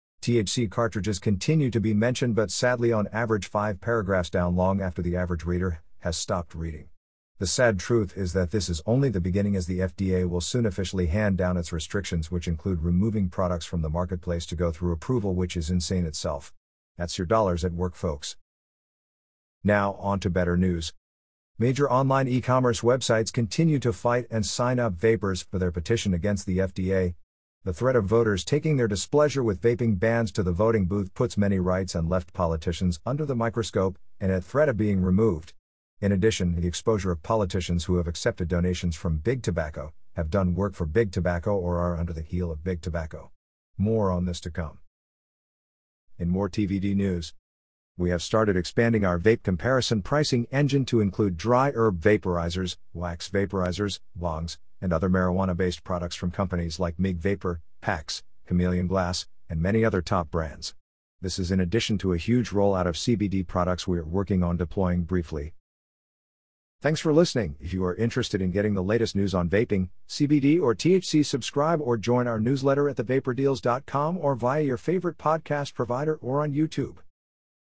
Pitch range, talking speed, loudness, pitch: 90-115 Hz, 180 wpm, -26 LUFS, 95 Hz